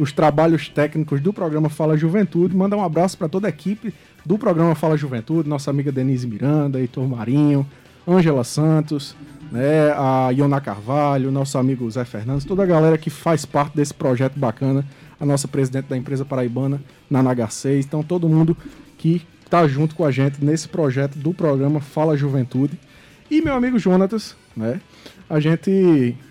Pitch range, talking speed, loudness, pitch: 135-165 Hz, 165 wpm, -19 LUFS, 145 Hz